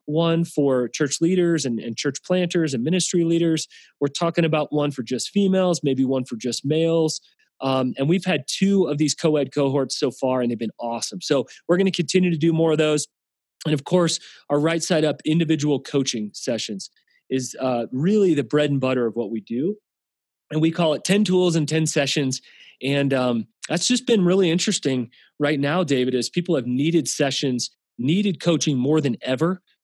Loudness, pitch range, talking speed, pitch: -22 LUFS, 130-170 Hz, 200 wpm, 150 Hz